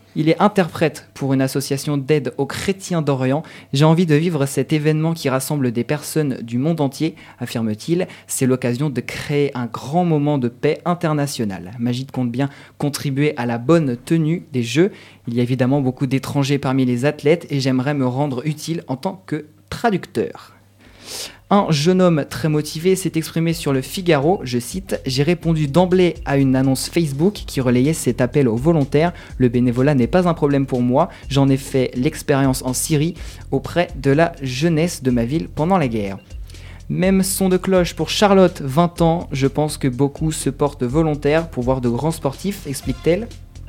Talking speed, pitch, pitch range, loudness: 180 wpm, 145 Hz, 130-160 Hz, -19 LUFS